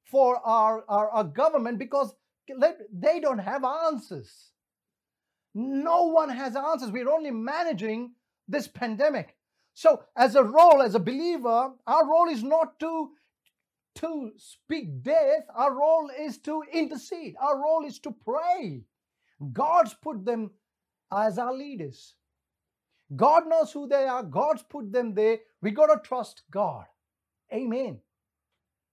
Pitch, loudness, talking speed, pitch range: 270 Hz, -25 LUFS, 135 wpm, 225-310 Hz